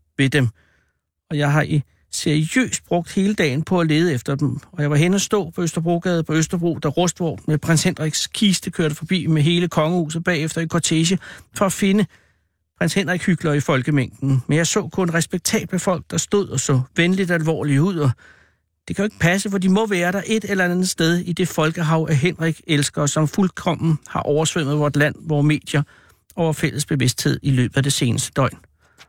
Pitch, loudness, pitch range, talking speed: 160 Hz, -20 LUFS, 145-180 Hz, 200 wpm